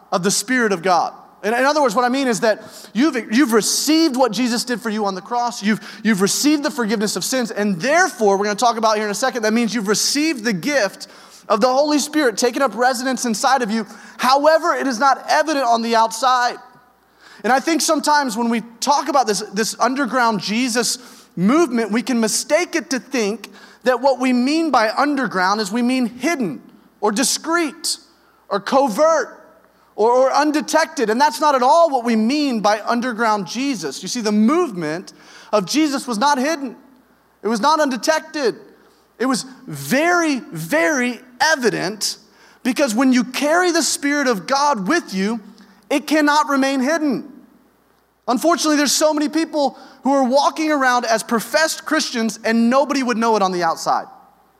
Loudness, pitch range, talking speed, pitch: -18 LUFS, 225-290 Hz, 180 wpm, 255 Hz